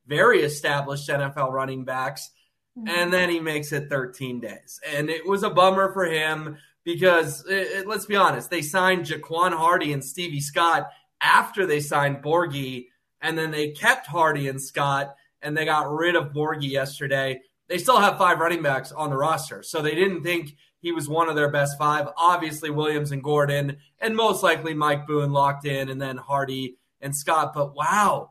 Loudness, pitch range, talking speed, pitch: -23 LUFS, 140-170 Hz, 185 wpm, 150 Hz